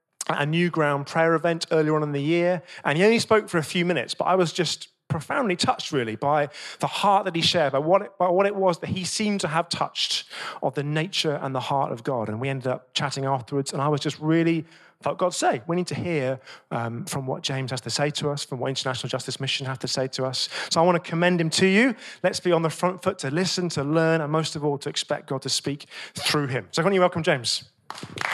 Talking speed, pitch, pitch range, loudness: 265 wpm, 155 Hz, 140-180 Hz, -24 LUFS